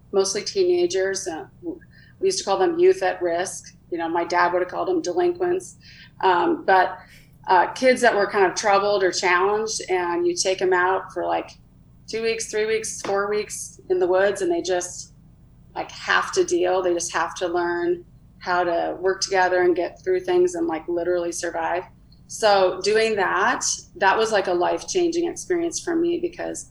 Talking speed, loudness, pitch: 185 wpm, -22 LUFS, 190 Hz